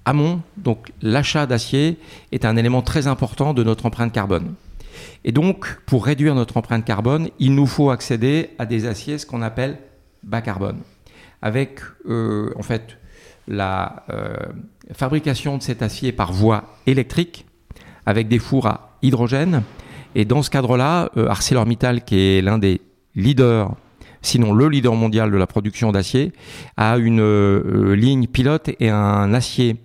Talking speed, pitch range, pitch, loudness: 155 wpm, 110-135 Hz, 120 Hz, -19 LUFS